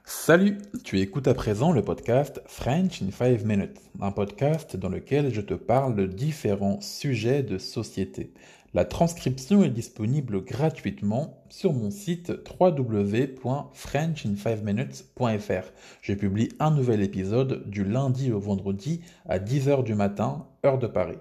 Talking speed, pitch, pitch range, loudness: 135 wpm, 120 Hz, 100-145 Hz, -26 LUFS